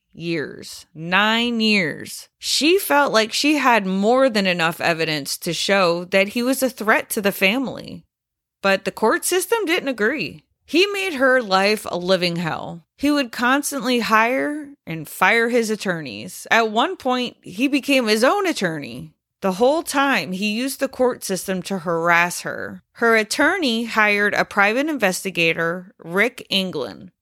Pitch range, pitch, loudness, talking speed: 190-265 Hz, 220 Hz, -19 LUFS, 155 wpm